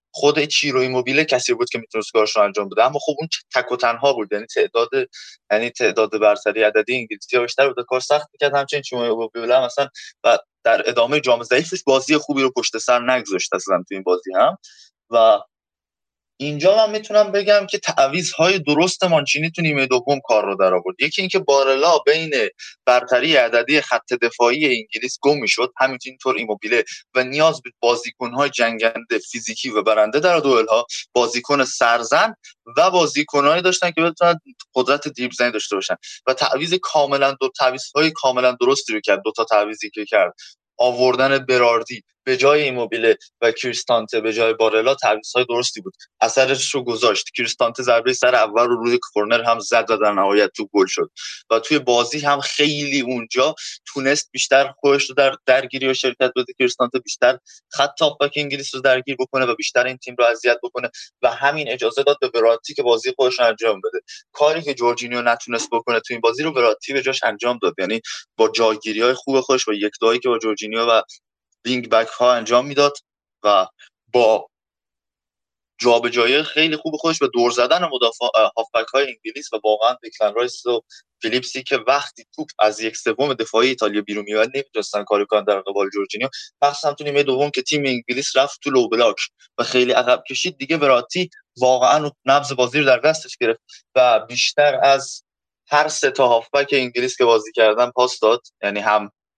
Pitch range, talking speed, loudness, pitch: 120-150 Hz, 175 wpm, -18 LUFS, 130 Hz